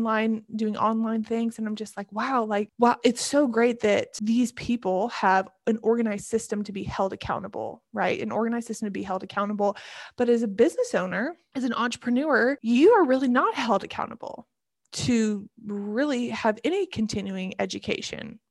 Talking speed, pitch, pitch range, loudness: 170 wpm, 225 Hz, 210-240 Hz, -25 LUFS